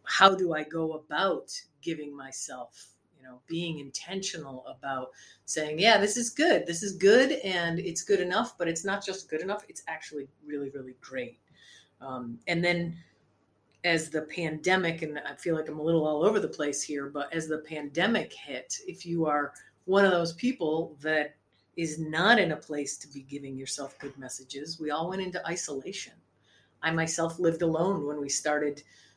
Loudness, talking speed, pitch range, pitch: -29 LUFS, 185 wpm, 145-180 Hz, 160 Hz